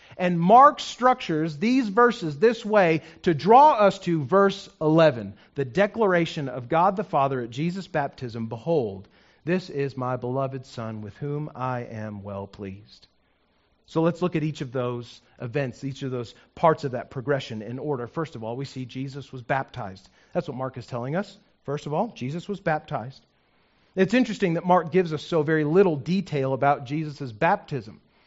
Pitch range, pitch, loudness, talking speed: 130-180 Hz, 150 Hz, -24 LUFS, 180 wpm